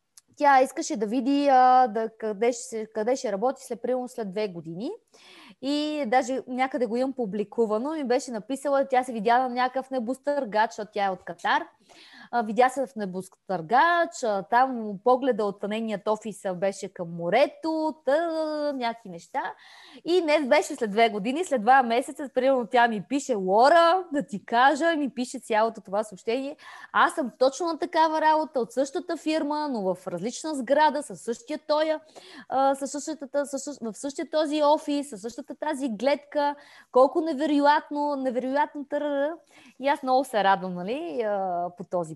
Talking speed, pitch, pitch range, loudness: 150 wpm, 260 Hz, 225-295 Hz, -25 LUFS